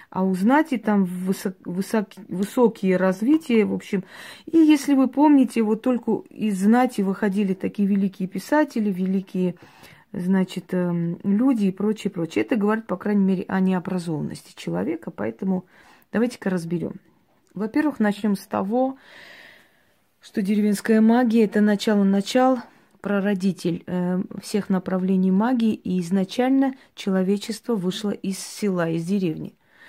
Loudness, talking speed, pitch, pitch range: -22 LUFS, 120 wpm, 200 Hz, 190-225 Hz